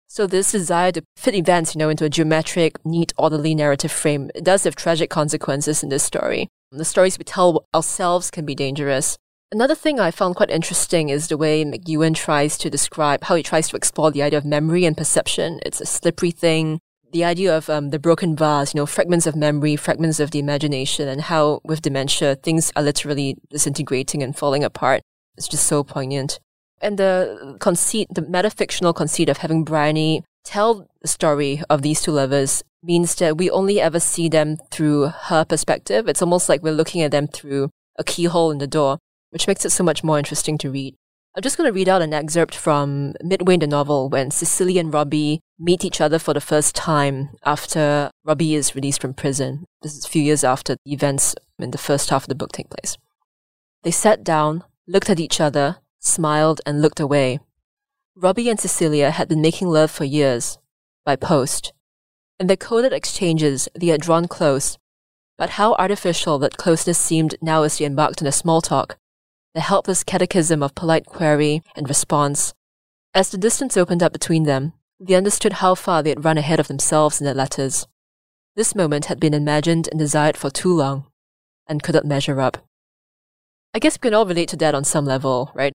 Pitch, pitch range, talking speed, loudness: 155 Hz, 145-170 Hz, 200 wpm, -19 LUFS